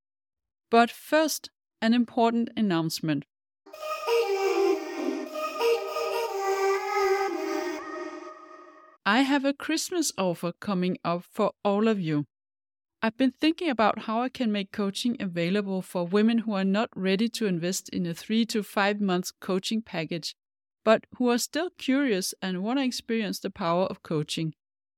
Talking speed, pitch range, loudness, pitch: 130 wpm, 190-310 Hz, -27 LUFS, 225 Hz